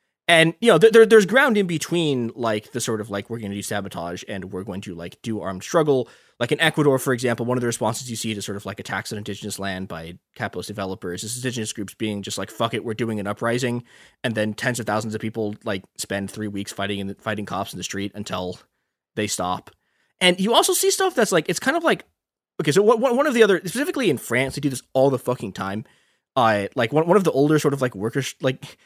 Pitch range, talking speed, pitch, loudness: 100-145 Hz, 250 wpm, 115 Hz, -22 LUFS